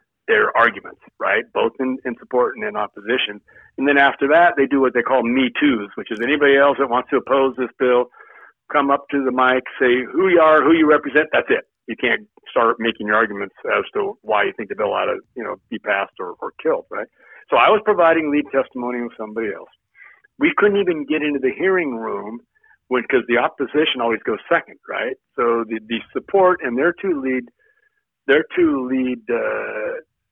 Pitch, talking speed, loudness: 150 Hz, 205 wpm, -18 LUFS